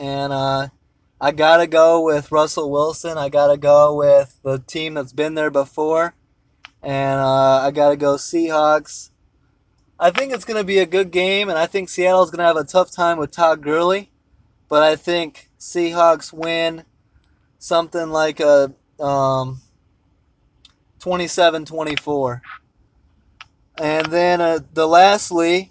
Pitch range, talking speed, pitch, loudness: 135-170 Hz, 140 wpm, 155 Hz, -17 LUFS